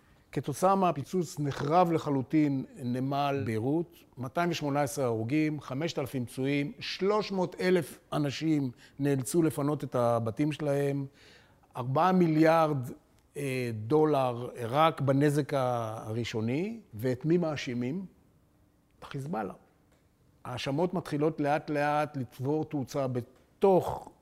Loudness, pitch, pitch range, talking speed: -30 LUFS, 145 Hz, 130-155 Hz, 85 wpm